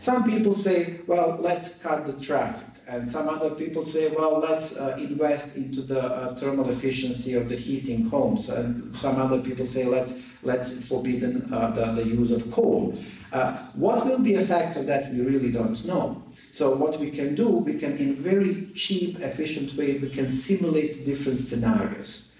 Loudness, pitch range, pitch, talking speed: -26 LUFS, 125-160 Hz, 140 Hz, 180 wpm